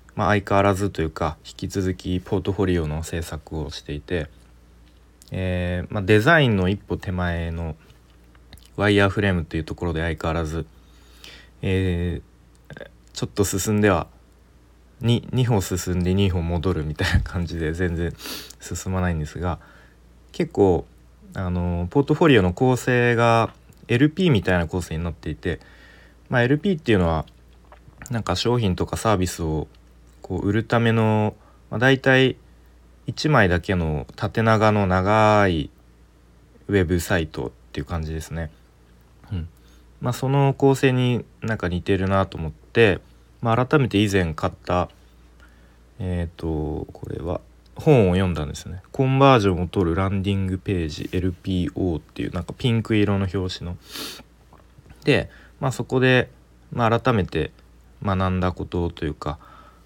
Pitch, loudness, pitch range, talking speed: 90 Hz, -22 LUFS, 80-105 Hz, 290 characters per minute